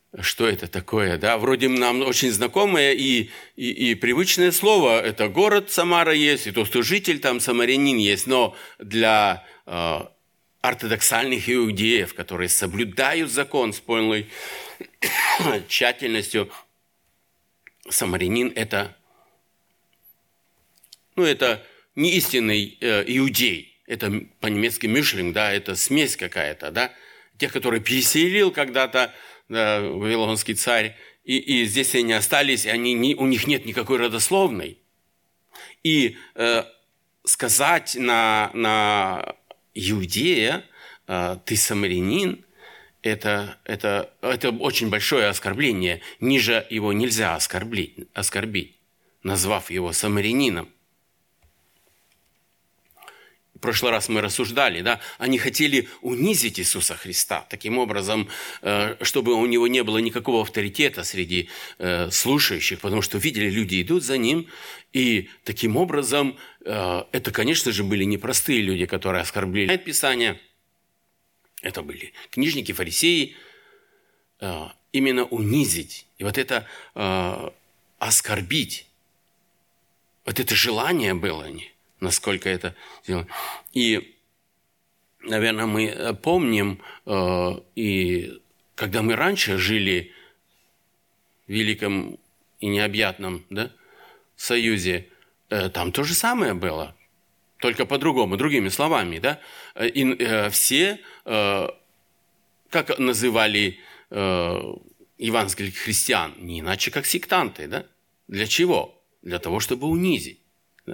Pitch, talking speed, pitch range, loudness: 110 Hz, 105 wpm, 100-130 Hz, -22 LUFS